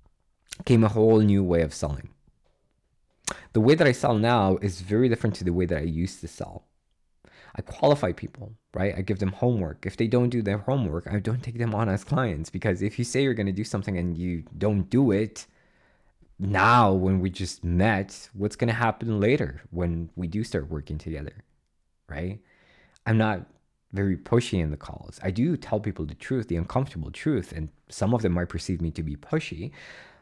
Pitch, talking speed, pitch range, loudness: 100 Hz, 205 wpm, 85-115 Hz, -26 LUFS